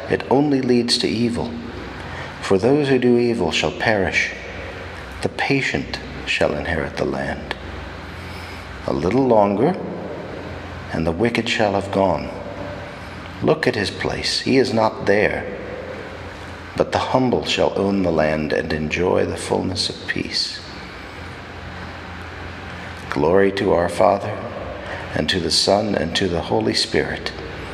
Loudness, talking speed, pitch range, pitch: -20 LUFS, 130 wpm, 85-100 Hz, 95 Hz